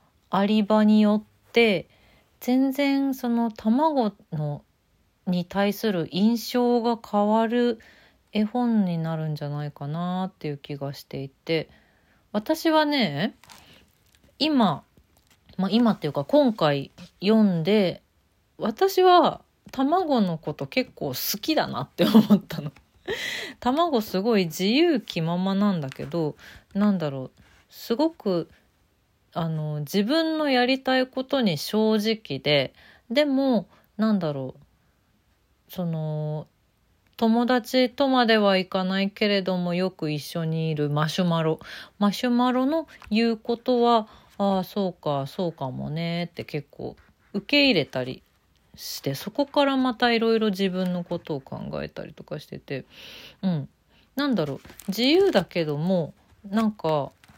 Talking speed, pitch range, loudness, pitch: 235 characters per minute, 160-240 Hz, -24 LUFS, 200 Hz